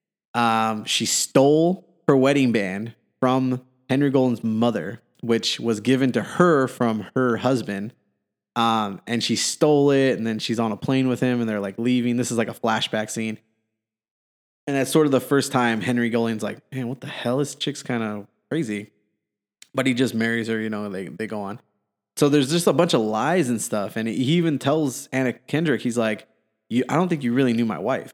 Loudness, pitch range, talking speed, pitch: -22 LUFS, 110-135 Hz, 210 wpm, 120 Hz